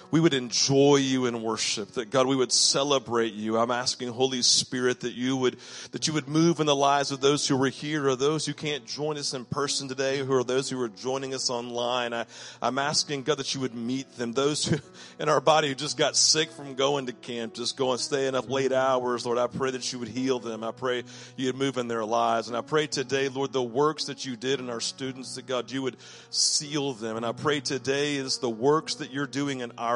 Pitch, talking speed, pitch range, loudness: 130 Hz, 250 wpm, 120-140 Hz, -26 LUFS